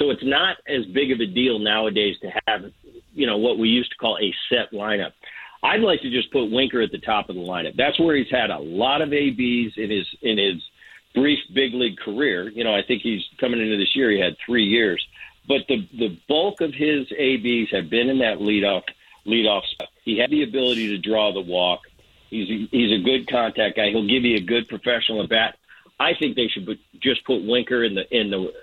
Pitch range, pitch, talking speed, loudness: 110-130 Hz, 120 Hz, 230 wpm, -21 LUFS